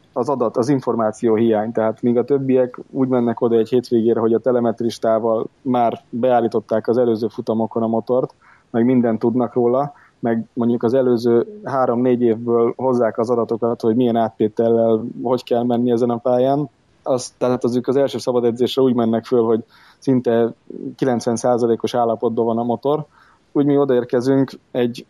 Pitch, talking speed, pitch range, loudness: 120 Hz, 165 wpm, 115-125 Hz, -18 LUFS